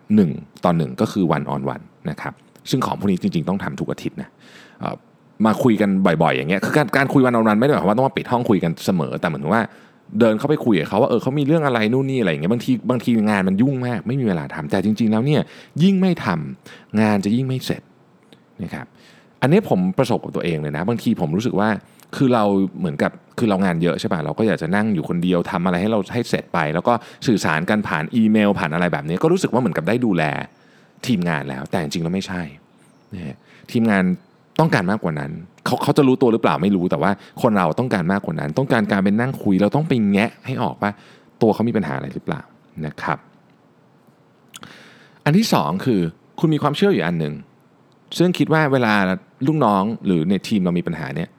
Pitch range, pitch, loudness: 95-145 Hz, 110 Hz, -19 LUFS